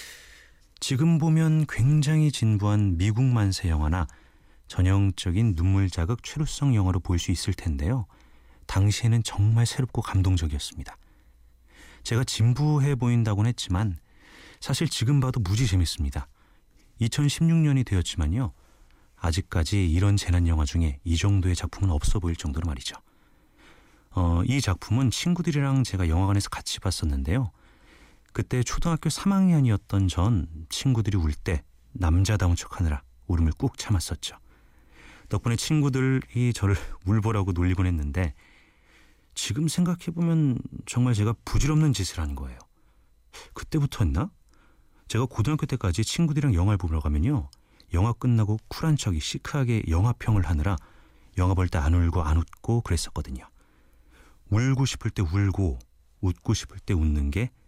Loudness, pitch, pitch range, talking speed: -26 LUFS, 100 Hz, 85-125 Hz, 305 characters per minute